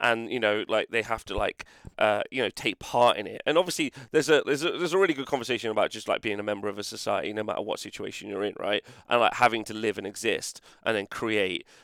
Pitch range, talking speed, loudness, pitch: 105-140 Hz, 265 wpm, -27 LUFS, 115 Hz